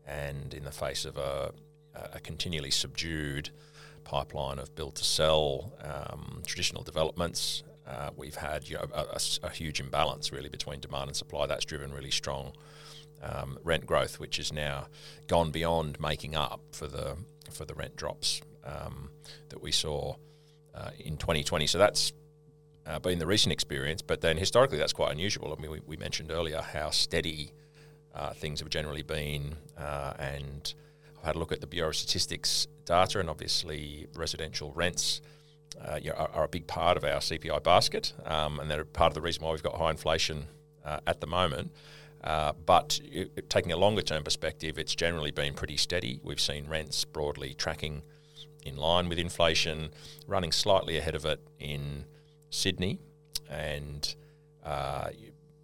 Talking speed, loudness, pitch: 170 wpm, -31 LUFS, 80 Hz